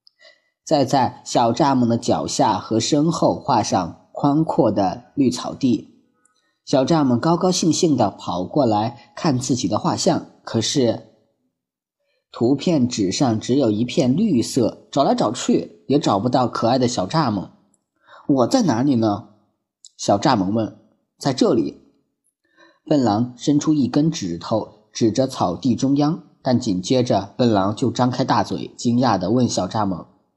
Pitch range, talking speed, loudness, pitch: 110-140 Hz, 210 characters per minute, -20 LUFS, 120 Hz